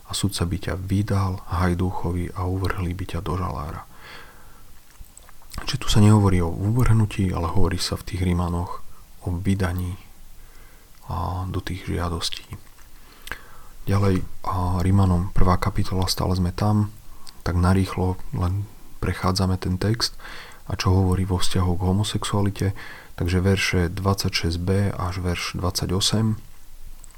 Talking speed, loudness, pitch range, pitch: 125 wpm, -24 LUFS, 90-100 Hz, 95 Hz